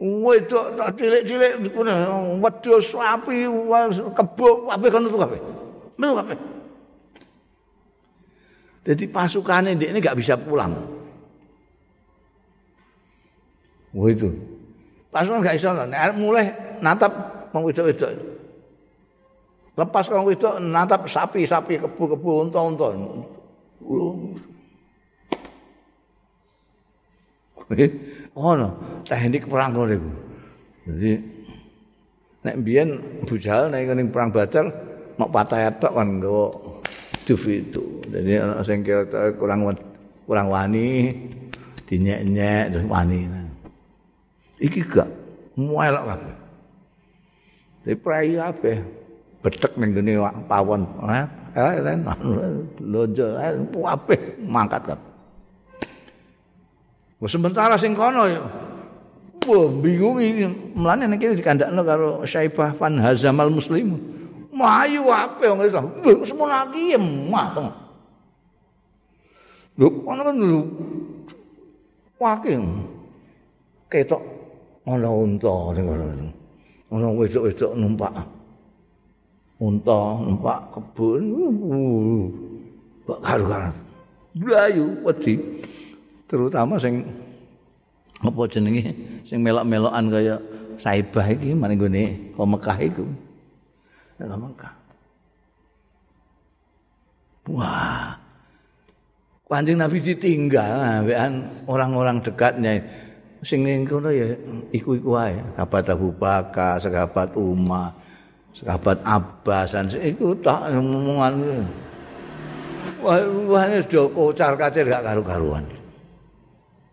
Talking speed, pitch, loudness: 75 wpm, 130 Hz, -21 LUFS